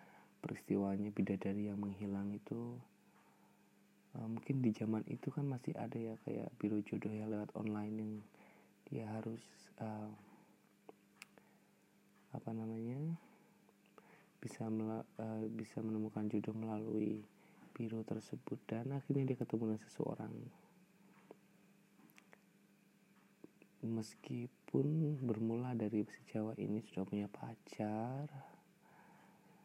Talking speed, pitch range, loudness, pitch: 100 wpm, 105-115 Hz, -43 LUFS, 110 Hz